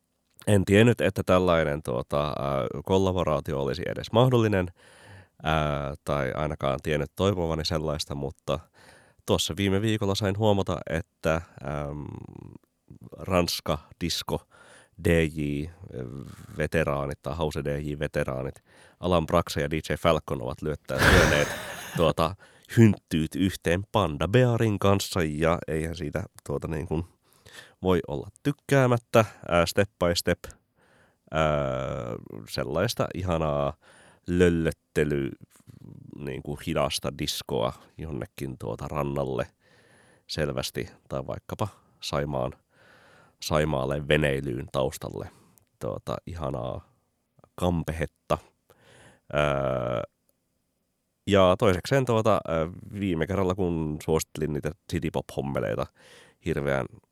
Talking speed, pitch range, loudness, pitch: 90 wpm, 70-95 Hz, -27 LUFS, 80 Hz